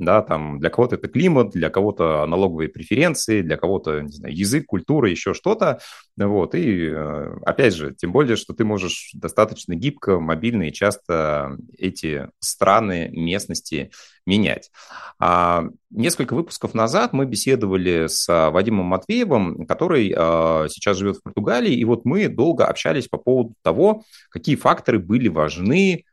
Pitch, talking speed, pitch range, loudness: 95 Hz, 140 wpm, 80-115 Hz, -20 LUFS